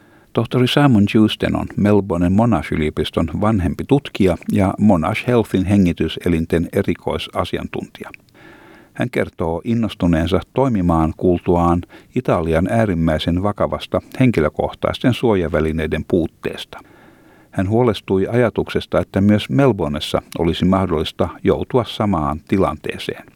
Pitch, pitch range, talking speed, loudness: 95 Hz, 85-110 Hz, 95 wpm, -18 LUFS